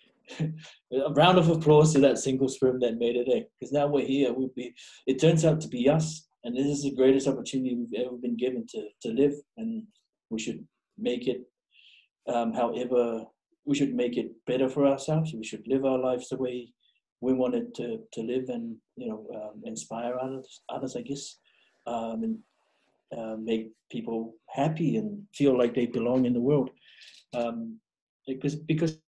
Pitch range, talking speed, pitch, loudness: 120-145 Hz, 180 wpm, 130 Hz, -28 LUFS